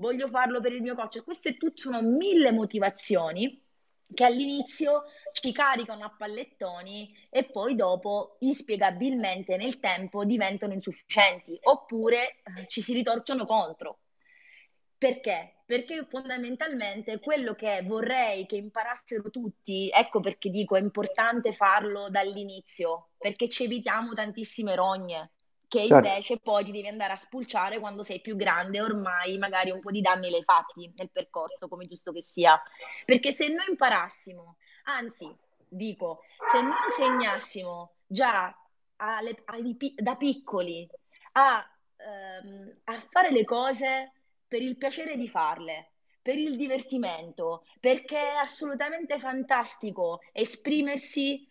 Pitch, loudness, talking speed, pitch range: 220 Hz, -28 LUFS, 130 wpm, 195-265 Hz